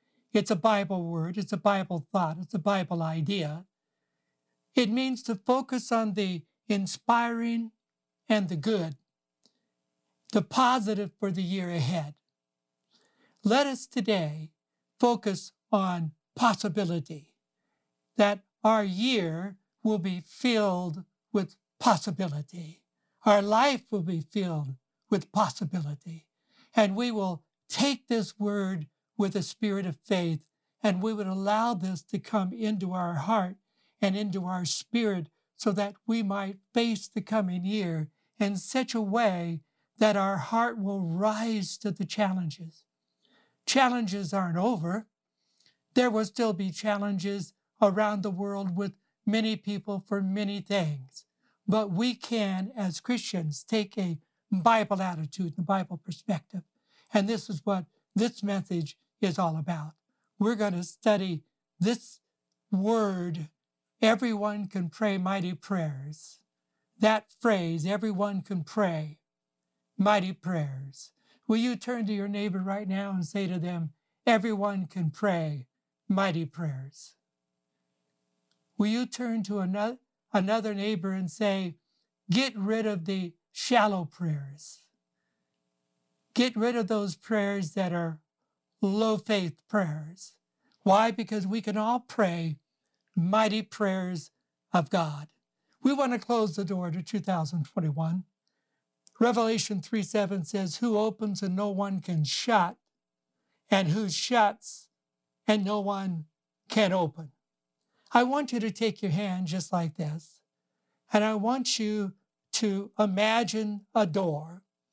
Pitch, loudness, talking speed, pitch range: 195 Hz, -29 LUFS, 130 wpm, 170-215 Hz